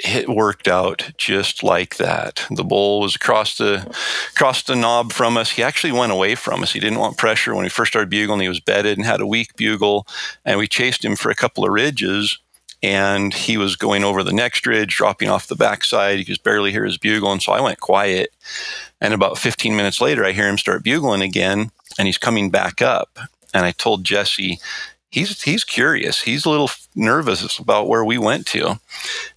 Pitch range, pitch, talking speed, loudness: 100-115 Hz, 105 Hz, 210 wpm, -18 LUFS